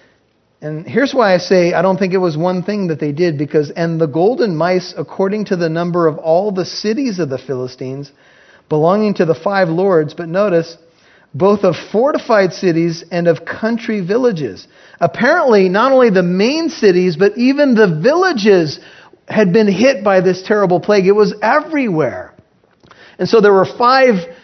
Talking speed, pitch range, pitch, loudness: 175 wpm, 170-215 Hz, 185 Hz, -14 LUFS